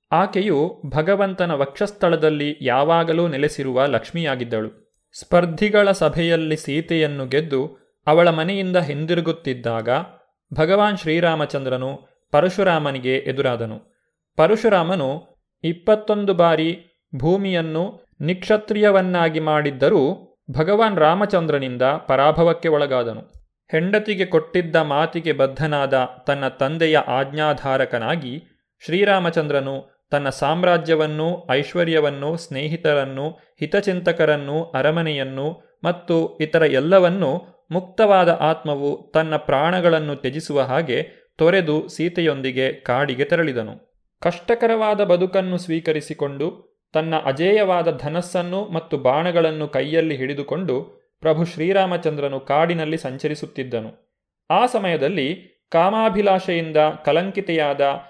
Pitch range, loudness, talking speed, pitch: 145-175 Hz, -20 LUFS, 75 wpm, 160 Hz